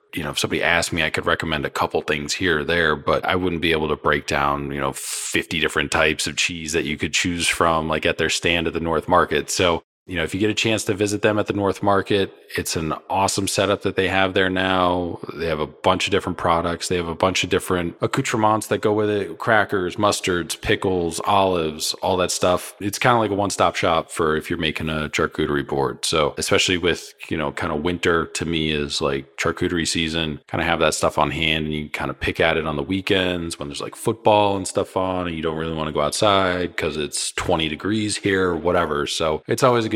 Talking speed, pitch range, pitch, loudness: 245 wpm, 80-100 Hz, 90 Hz, -21 LUFS